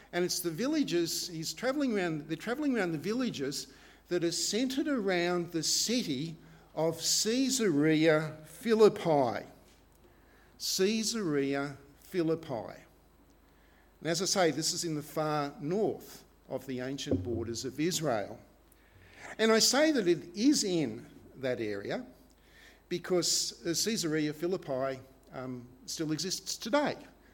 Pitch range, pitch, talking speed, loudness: 135-195 Hz, 165 Hz, 120 wpm, -31 LUFS